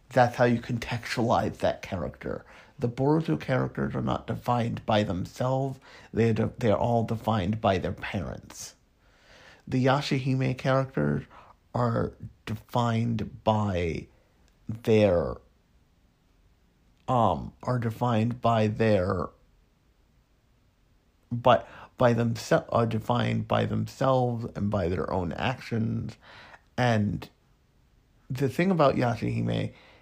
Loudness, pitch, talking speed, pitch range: -27 LUFS, 115 Hz, 100 wpm, 105-125 Hz